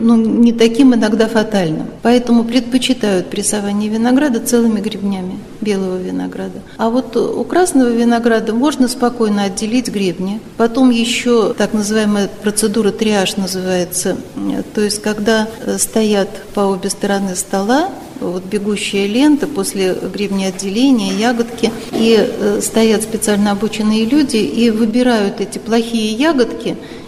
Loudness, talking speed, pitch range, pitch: -15 LUFS, 120 wpm, 200-235 Hz, 220 Hz